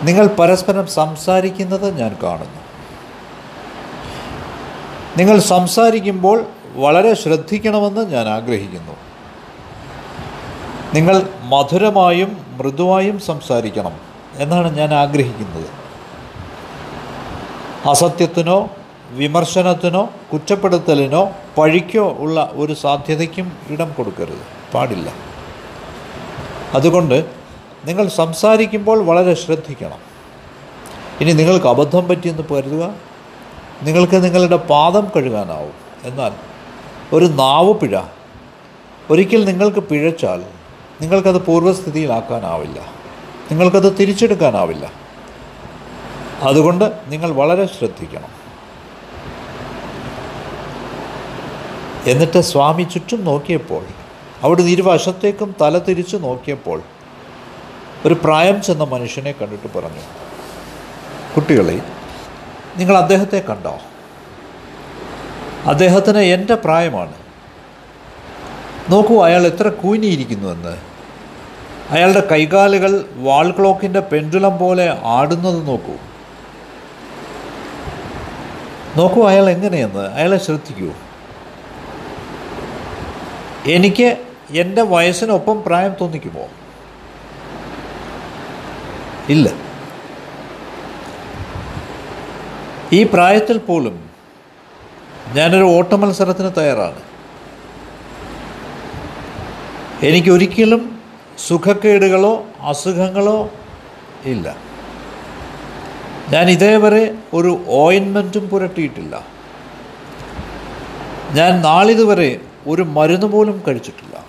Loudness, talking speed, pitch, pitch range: -14 LUFS, 65 wpm, 180 Hz, 150-195 Hz